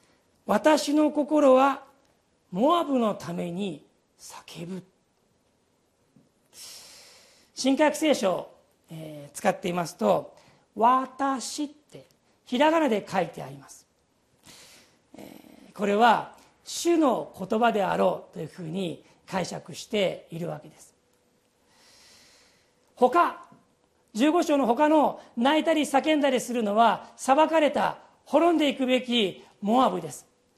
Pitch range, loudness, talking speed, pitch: 205-295 Hz, -25 LUFS, 200 characters per minute, 260 Hz